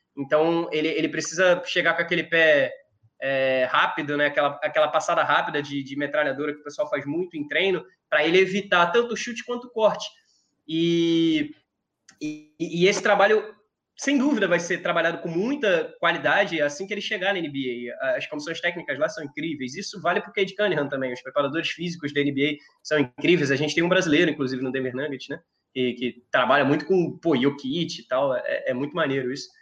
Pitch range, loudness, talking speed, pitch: 145-200 Hz, -24 LUFS, 195 wpm, 165 Hz